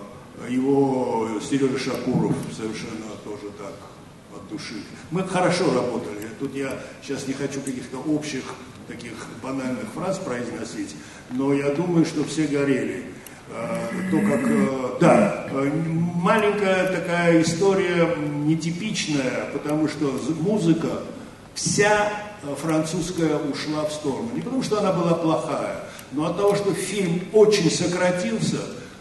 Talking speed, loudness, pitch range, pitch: 115 wpm, -23 LUFS, 135-180 Hz, 155 Hz